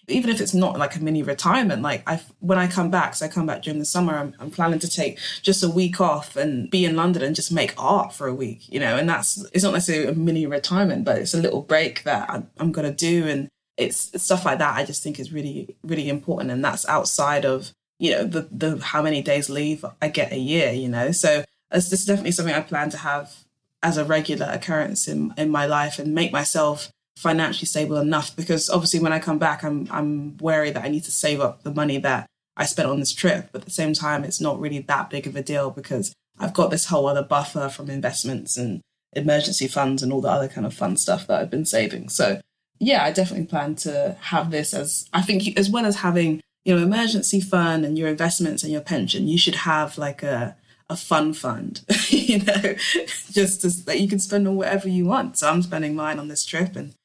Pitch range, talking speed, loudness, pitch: 145-180 Hz, 240 wpm, -22 LUFS, 155 Hz